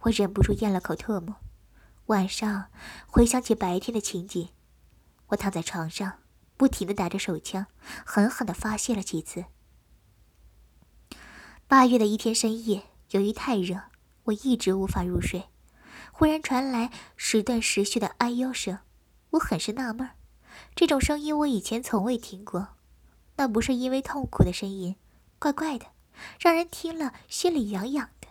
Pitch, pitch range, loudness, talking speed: 220 Hz, 195-255 Hz, -27 LUFS, 225 characters per minute